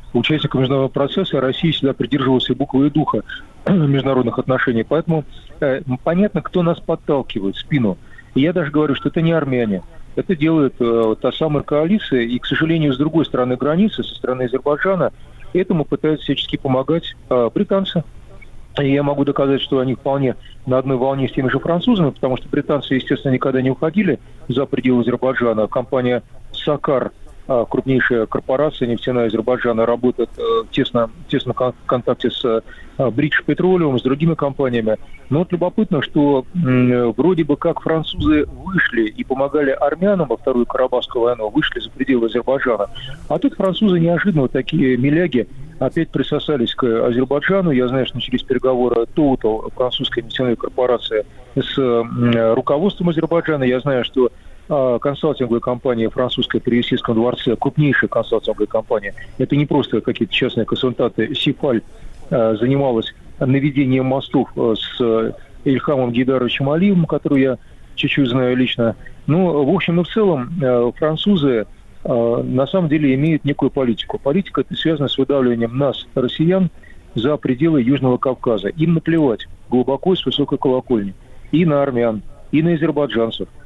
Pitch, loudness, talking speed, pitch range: 135 Hz, -18 LUFS, 155 wpm, 125-155 Hz